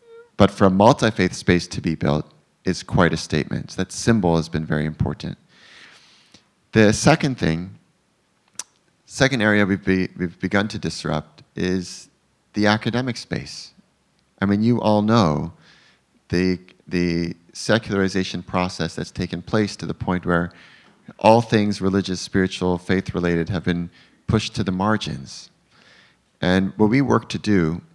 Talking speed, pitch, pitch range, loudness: 150 wpm, 95 Hz, 85-110 Hz, -21 LUFS